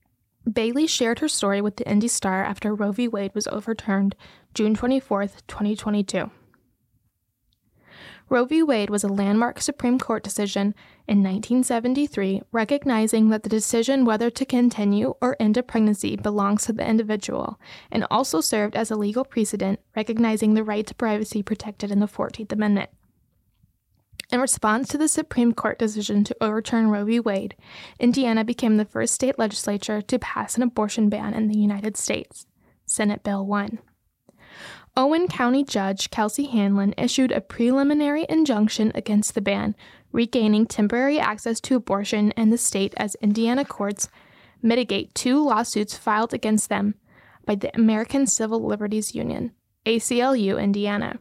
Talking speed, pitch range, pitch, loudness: 150 wpm, 210-245 Hz, 220 Hz, -23 LUFS